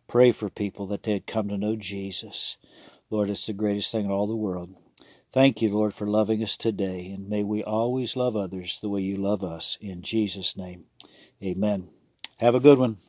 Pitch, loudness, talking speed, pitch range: 105 Hz, -26 LUFS, 205 wpm, 95-110 Hz